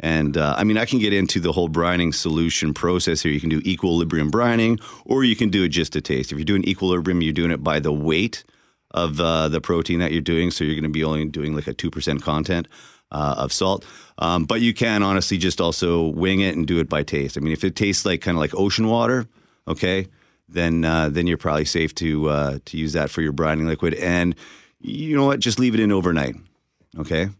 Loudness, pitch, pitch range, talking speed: -21 LUFS, 85 Hz, 80-95 Hz, 240 wpm